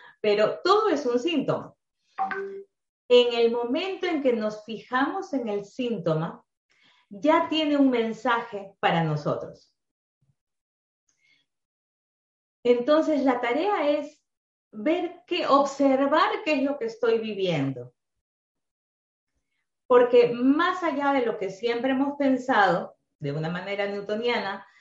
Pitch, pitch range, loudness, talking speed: 240 Hz, 200-290 Hz, -25 LUFS, 115 wpm